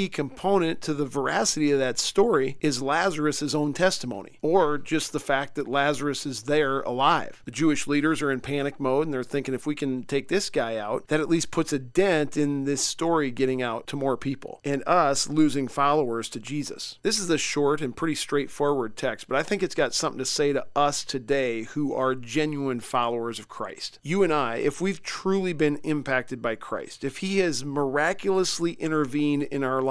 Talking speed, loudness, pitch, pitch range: 200 wpm, -26 LUFS, 145 Hz, 135-155 Hz